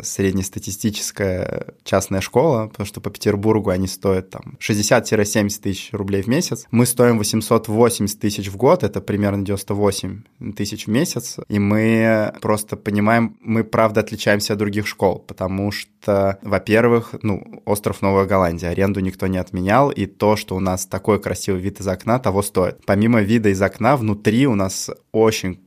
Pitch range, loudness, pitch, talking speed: 100-110 Hz, -19 LUFS, 105 Hz, 160 wpm